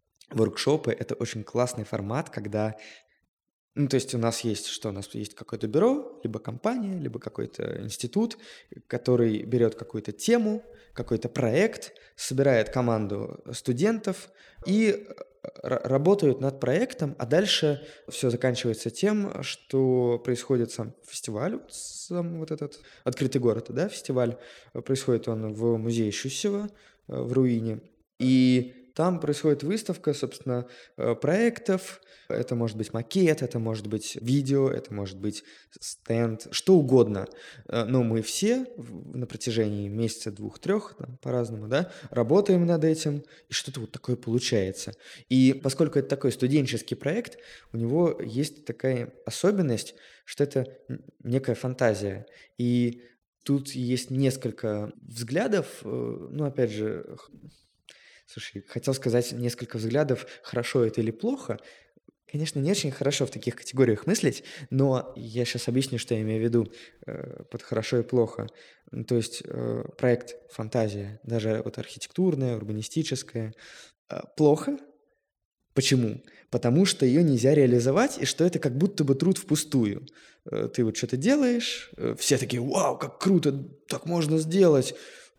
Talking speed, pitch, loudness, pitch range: 130 wpm, 125 Hz, -27 LUFS, 115-155 Hz